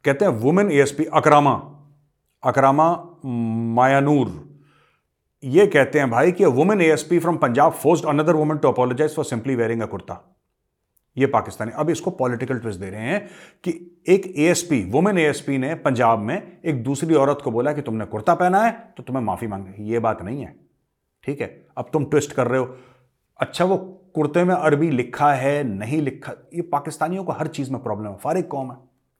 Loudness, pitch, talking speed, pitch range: -20 LUFS, 140 Hz, 195 wpm, 125-160 Hz